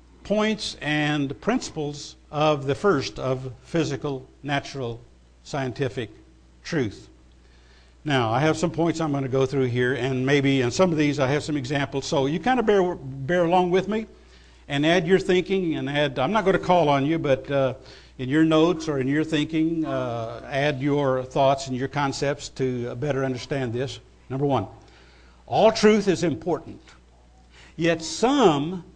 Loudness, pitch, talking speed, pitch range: -24 LUFS, 140 Hz, 170 wpm, 130-160 Hz